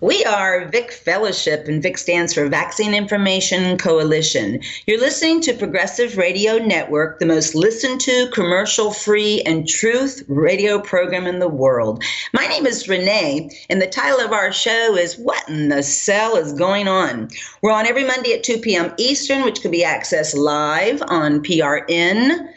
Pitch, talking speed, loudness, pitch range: 195 Hz, 170 wpm, -17 LUFS, 170-235 Hz